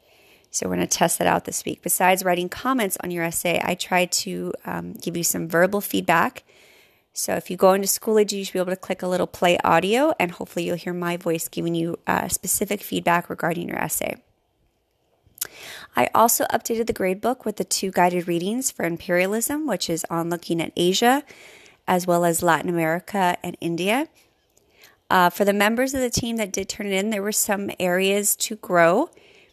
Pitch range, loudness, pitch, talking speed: 175-210 Hz, -22 LUFS, 185 Hz, 200 wpm